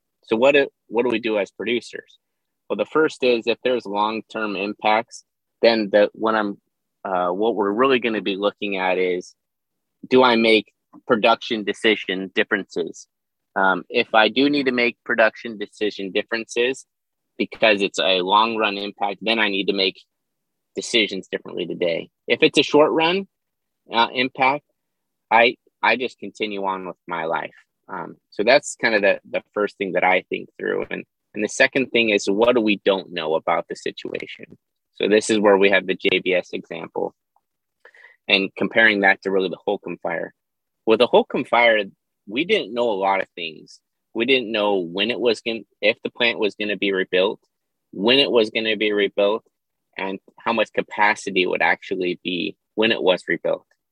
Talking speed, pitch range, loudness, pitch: 180 wpm, 100-120 Hz, -20 LUFS, 105 Hz